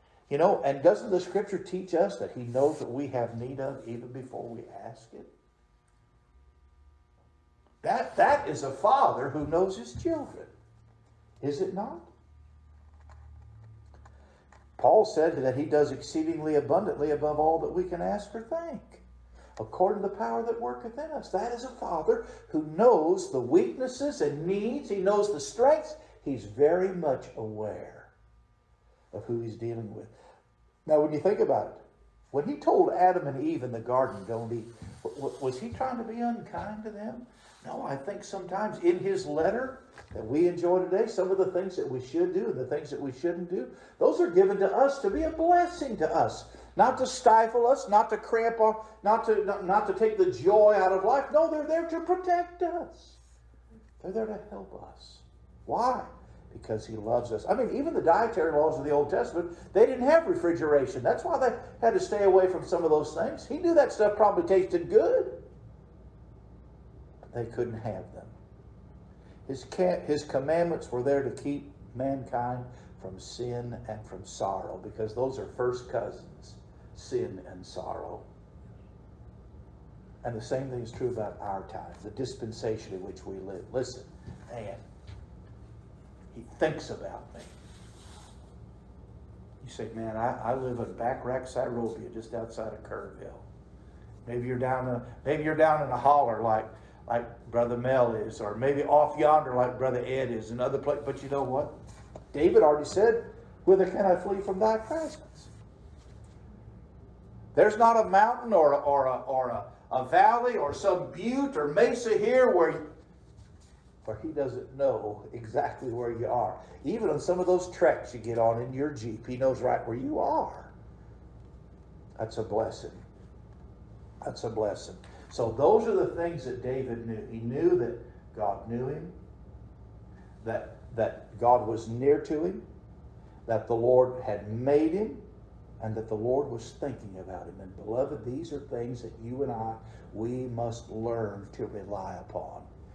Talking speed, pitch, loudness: 170 wpm, 140 Hz, -28 LUFS